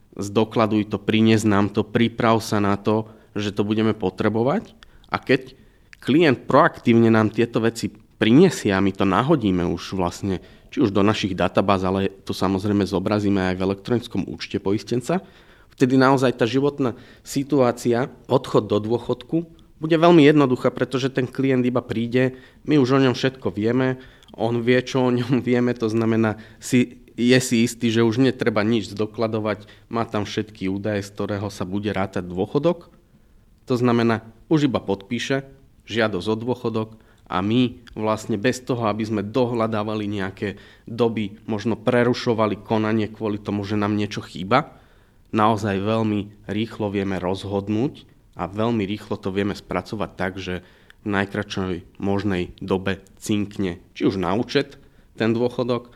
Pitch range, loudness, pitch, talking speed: 100-120 Hz, -22 LUFS, 110 Hz, 150 wpm